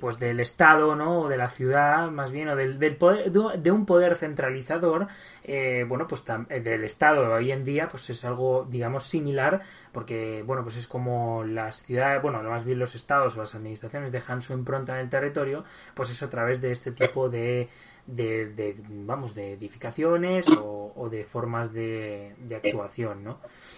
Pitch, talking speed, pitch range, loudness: 125 Hz, 185 wpm, 115-145 Hz, -26 LUFS